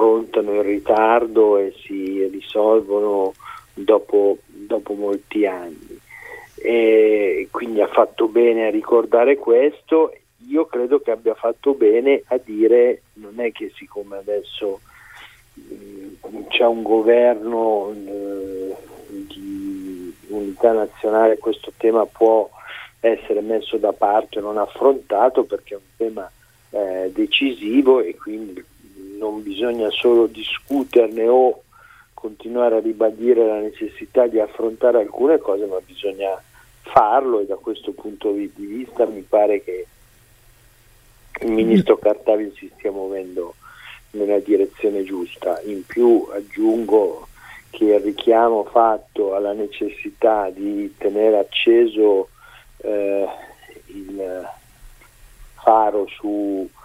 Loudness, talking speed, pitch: -19 LUFS, 115 wpm, 120 Hz